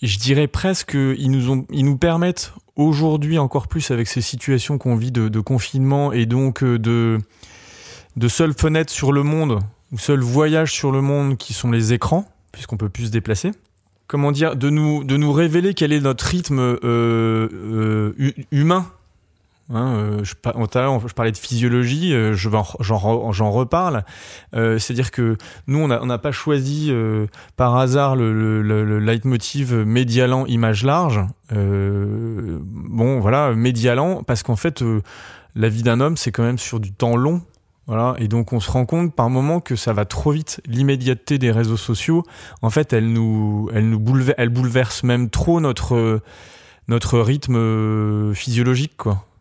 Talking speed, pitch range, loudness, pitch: 180 wpm, 110-140 Hz, -19 LUFS, 120 Hz